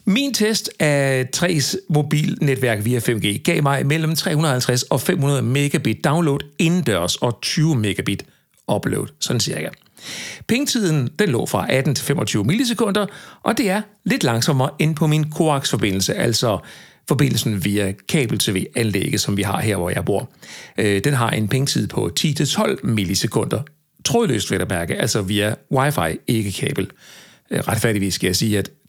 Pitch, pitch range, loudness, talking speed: 140 Hz, 115-165 Hz, -19 LUFS, 150 wpm